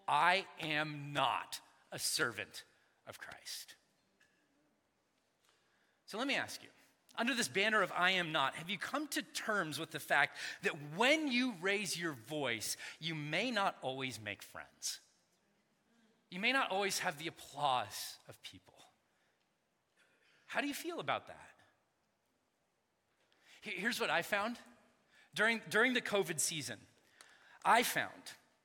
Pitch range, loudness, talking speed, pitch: 155-230 Hz, -36 LUFS, 135 wpm, 195 Hz